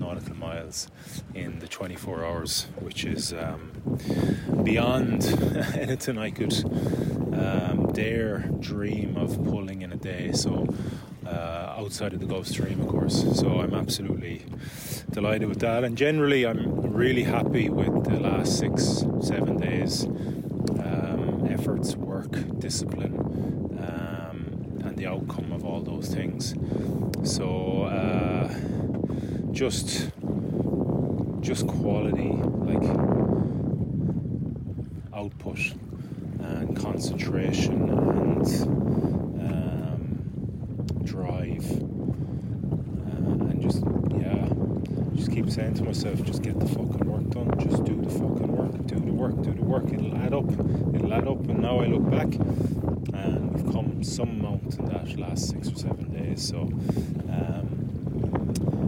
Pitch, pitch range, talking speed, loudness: 115 Hz, 100-130 Hz, 120 wpm, -27 LUFS